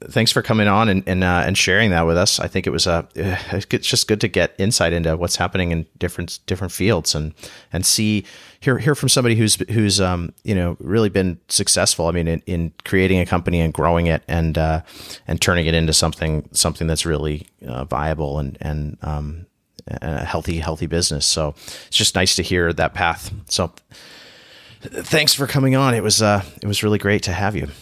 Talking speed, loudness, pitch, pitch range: 210 wpm, -18 LUFS, 90 Hz, 80-100 Hz